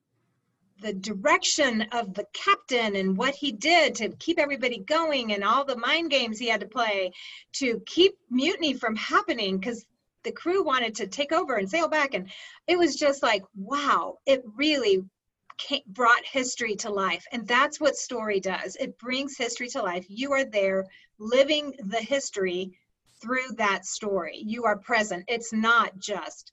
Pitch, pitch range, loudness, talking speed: 240 Hz, 205-285 Hz, -26 LUFS, 170 wpm